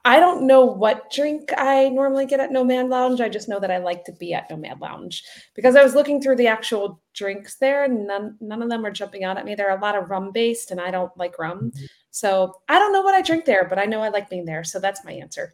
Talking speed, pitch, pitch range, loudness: 285 wpm, 215 Hz, 190-265 Hz, -20 LUFS